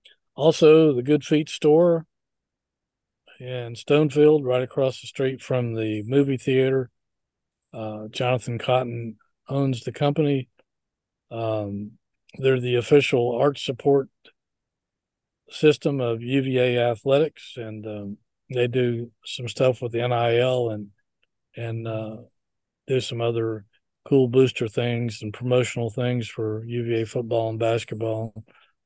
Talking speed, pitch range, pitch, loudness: 120 wpm, 115-135 Hz, 120 Hz, -23 LUFS